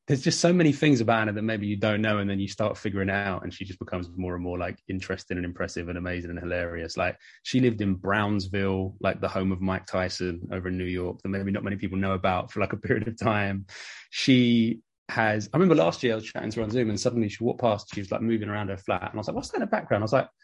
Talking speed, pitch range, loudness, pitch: 290 wpm, 95-110 Hz, -27 LUFS, 100 Hz